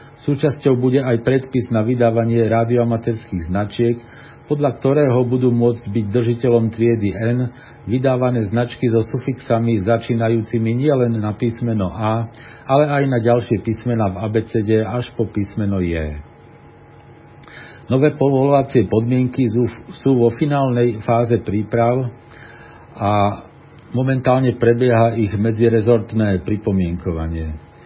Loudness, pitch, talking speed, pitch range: -18 LUFS, 120 Hz, 110 wpm, 110-125 Hz